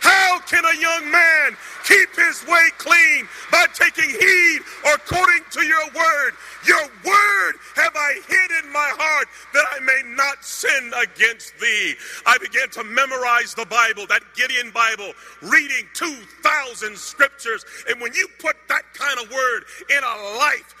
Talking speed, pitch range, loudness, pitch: 160 wpm, 265-340 Hz, -17 LUFS, 310 Hz